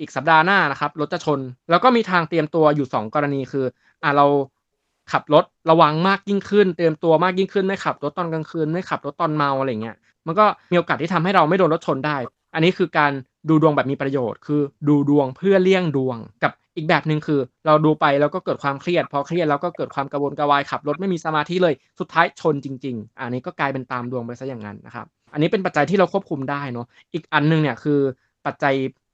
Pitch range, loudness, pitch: 140-170 Hz, -20 LUFS, 150 Hz